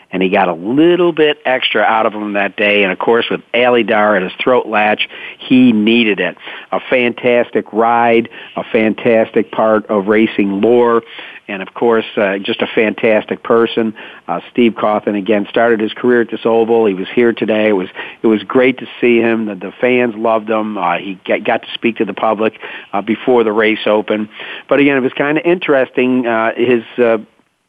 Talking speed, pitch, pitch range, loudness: 200 wpm, 115 Hz, 105-120 Hz, -13 LUFS